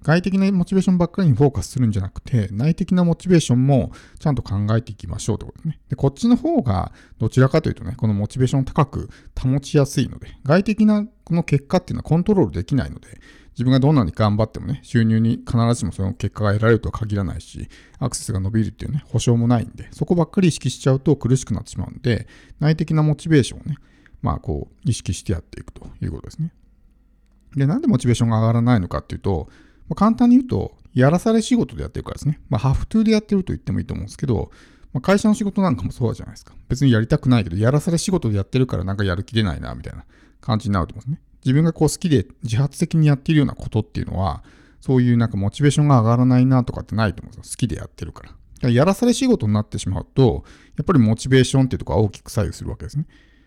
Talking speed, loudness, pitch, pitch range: 550 characters per minute, -20 LUFS, 125 Hz, 110-155 Hz